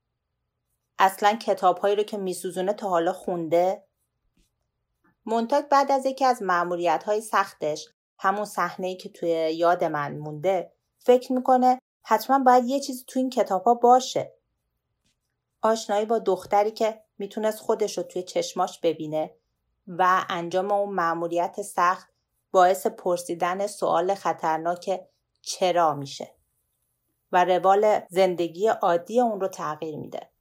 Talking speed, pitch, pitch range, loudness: 120 wpm, 190 Hz, 175-215 Hz, -24 LUFS